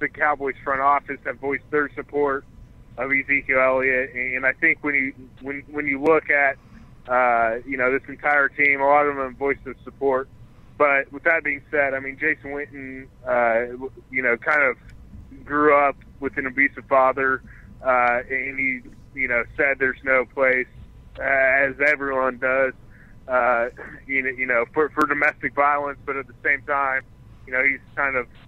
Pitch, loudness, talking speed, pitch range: 135 Hz, -21 LUFS, 180 wpm, 125-140 Hz